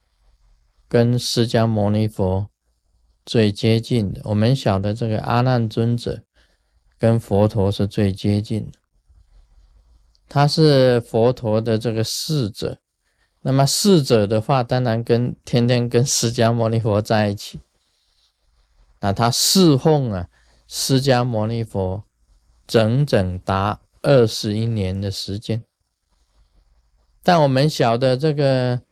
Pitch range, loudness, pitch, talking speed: 95-120 Hz, -19 LUFS, 110 Hz, 175 characters per minute